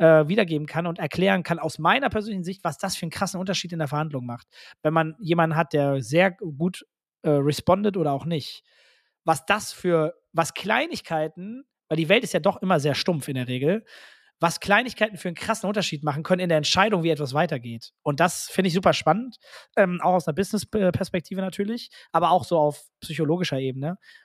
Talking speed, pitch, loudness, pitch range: 200 wpm, 170 Hz, -24 LUFS, 155-195 Hz